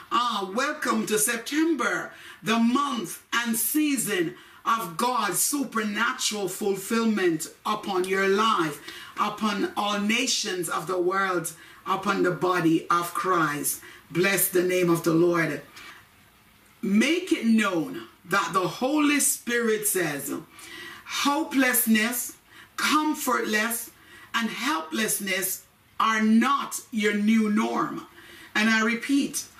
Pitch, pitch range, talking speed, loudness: 215 Hz, 190-255 Hz, 105 wpm, -25 LUFS